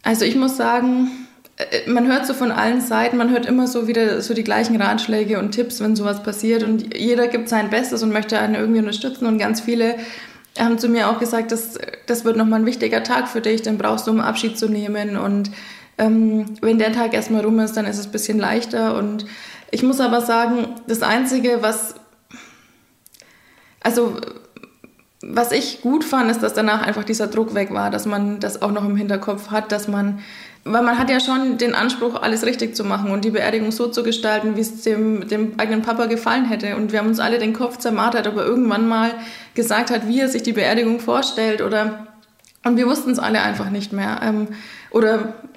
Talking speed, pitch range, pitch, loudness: 210 wpm, 215-235 Hz, 225 Hz, -19 LUFS